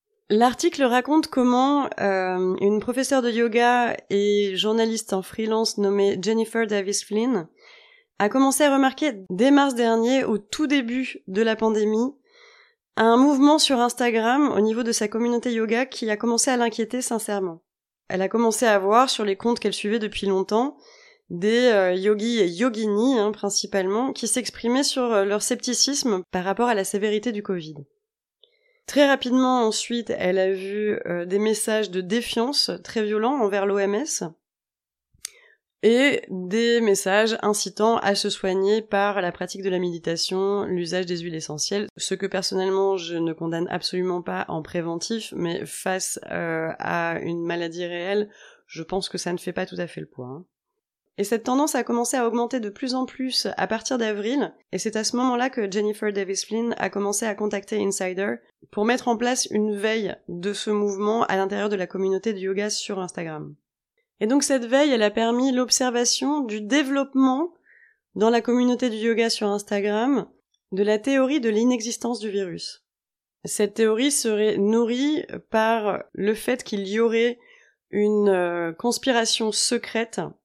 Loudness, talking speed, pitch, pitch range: -23 LUFS, 165 wpm, 220 Hz, 200-245 Hz